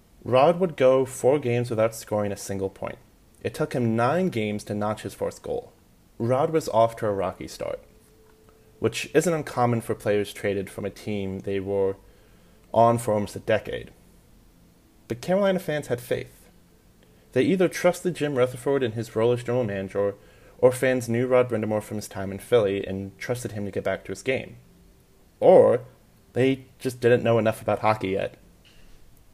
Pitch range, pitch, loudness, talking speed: 100-130 Hz, 115 Hz, -25 LUFS, 175 wpm